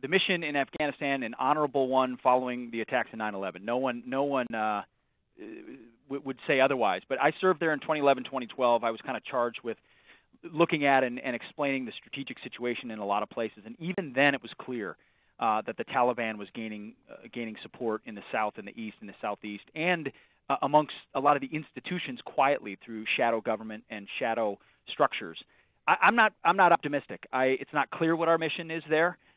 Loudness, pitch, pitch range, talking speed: -29 LUFS, 130 Hz, 115-150 Hz, 205 wpm